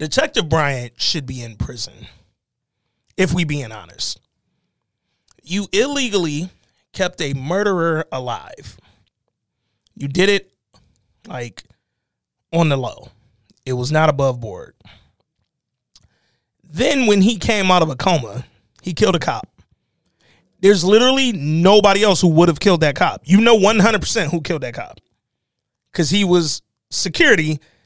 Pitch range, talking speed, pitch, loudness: 125-195 Hz, 140 wpm, 160 Hz, -17 LUFS